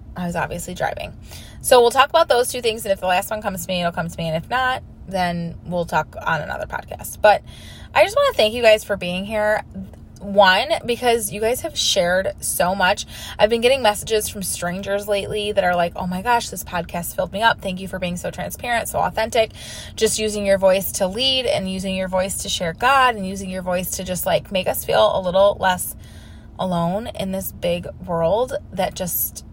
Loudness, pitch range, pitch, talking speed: -20 LUFS, 175-220 Hz, 190 Hz, 225 wpm